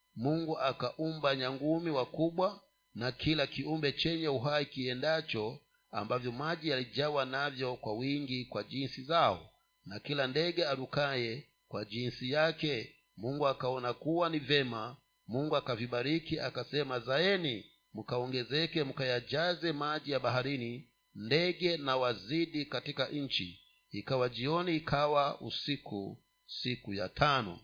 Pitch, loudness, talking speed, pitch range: 140 Hz, -34 LUFS, 115 wpm, 125-155 Hz